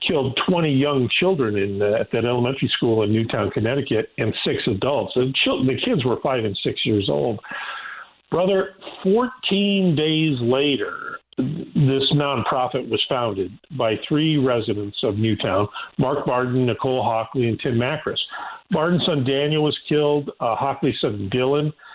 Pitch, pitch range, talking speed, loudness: 135 Hz, 115-150 Hz, 150 wpm, -21 LUFS